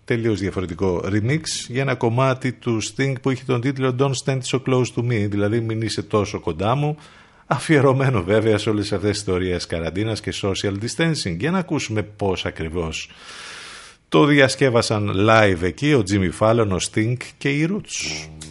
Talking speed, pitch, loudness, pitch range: 170 wpm, 110 Hz, -21 LUFS, 100-135 Hz